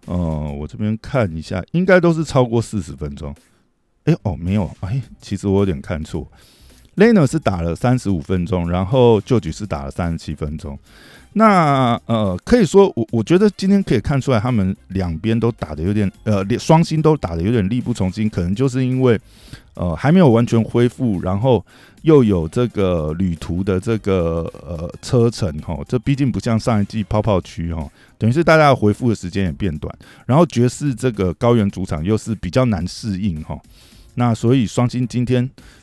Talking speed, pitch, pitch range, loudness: 285 characters per minute, 110 Hz, 90-125 Hz, -18 LUFS